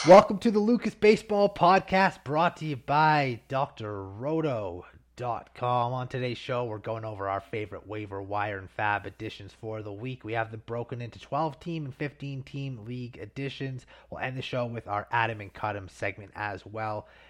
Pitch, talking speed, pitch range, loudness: 120 Hz, 175 wpm, 105-145 Hz, -29 LUFS